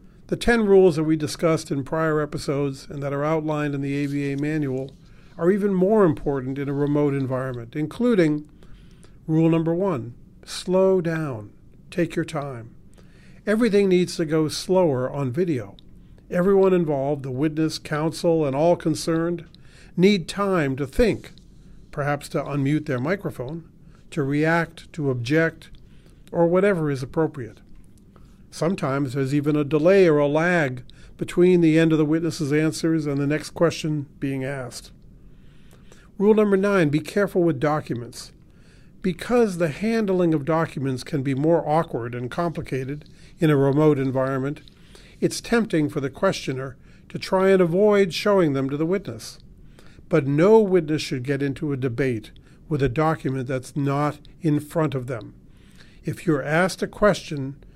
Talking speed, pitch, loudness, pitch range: 150 wpm, 155 Hz, -22 LUFS, 140-175 Hz